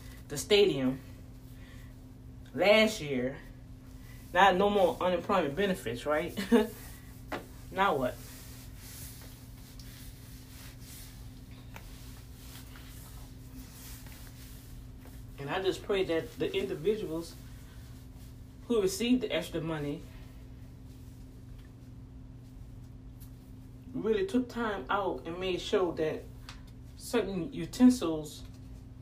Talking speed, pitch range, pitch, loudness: 70 wpm, 125-185 Hz, 130 Hz, -30 LUFS